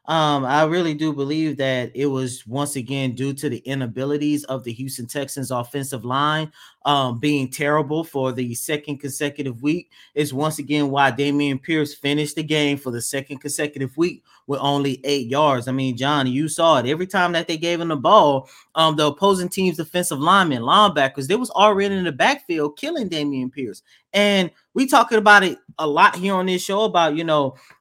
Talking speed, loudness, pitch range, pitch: 195 wpm, -20 LUFS, 135-165 Hz, 145 Hz